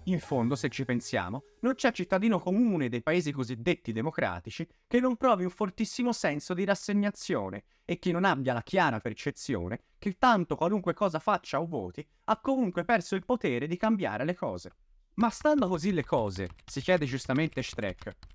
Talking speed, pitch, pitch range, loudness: 175 wpm, 175 Hz, 130-205 Hz, -30 LUFS